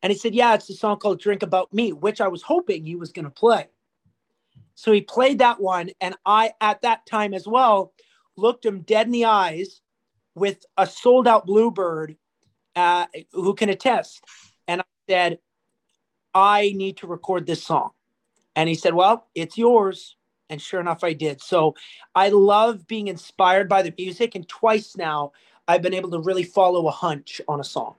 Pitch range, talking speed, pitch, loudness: 175-220 Hz, 190 wpm, 195 Hz, -21 LUFS